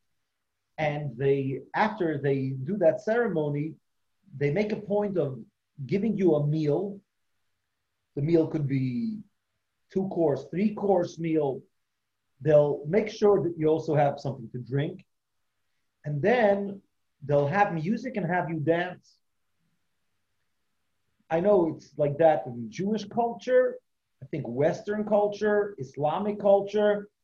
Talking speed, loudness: 130 wpm, -27 LUFS